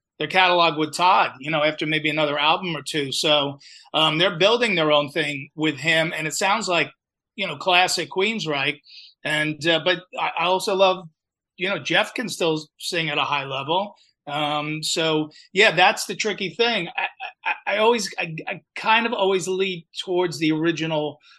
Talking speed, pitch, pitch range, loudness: 180 wpm, 160 Hz, 150-185 Hz, -21 LUFS